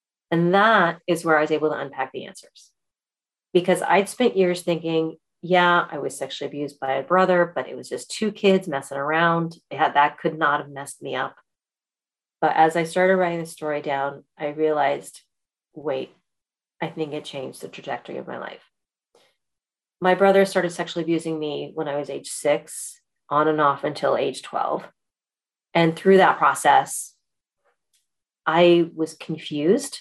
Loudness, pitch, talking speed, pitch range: -22 LUFS, 160 Hz, 170 wpm, 145-175 Hz